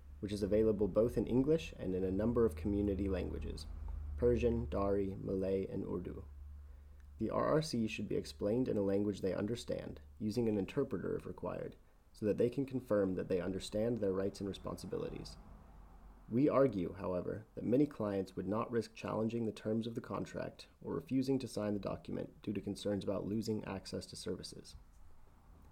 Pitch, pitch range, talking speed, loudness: 100 Hz, 85-110 Hz, 175 wpm, -37 LUFS